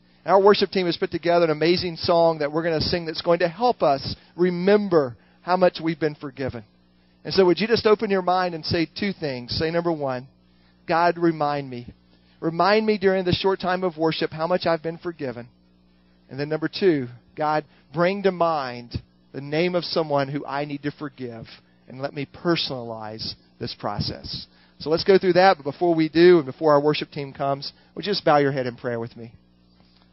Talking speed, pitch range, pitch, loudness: 205 wpm, 120-175 Hz, 155 Hz, -22 LUFS